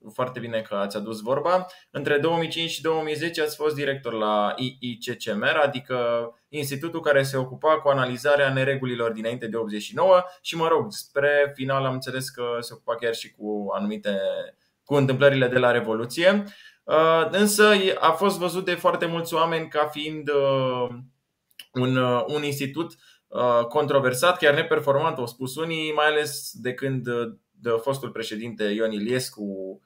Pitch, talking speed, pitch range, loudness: 140 Hz, 145 wpm, 120-160 Hz, -24 LUFS